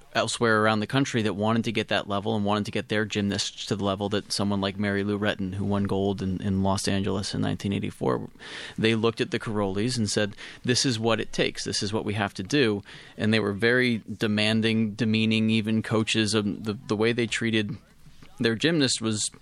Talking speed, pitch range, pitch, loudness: 215 wpm, 100-115 Hz, 110 Hz, -26 LUFS